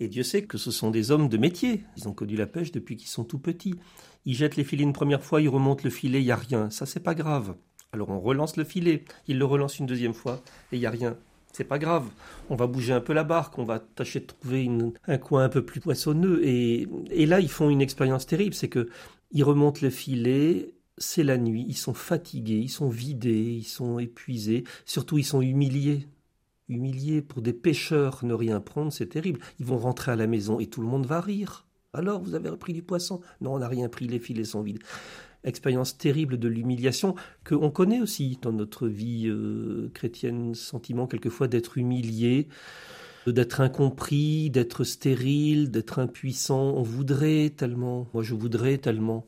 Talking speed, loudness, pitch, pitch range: 210 wpm, -27 LUFS, 130 Hz, 120-150 Hz